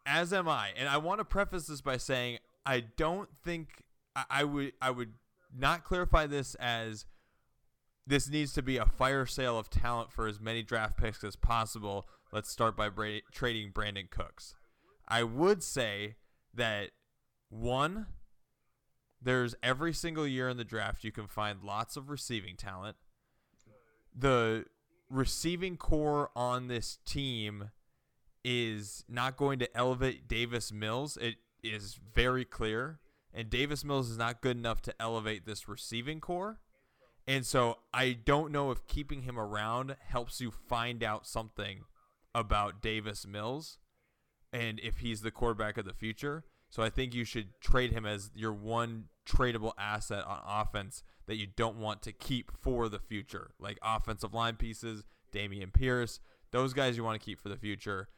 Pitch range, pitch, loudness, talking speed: 110-130 Hz, 115 Hz, -35 LUFS, 160 wpm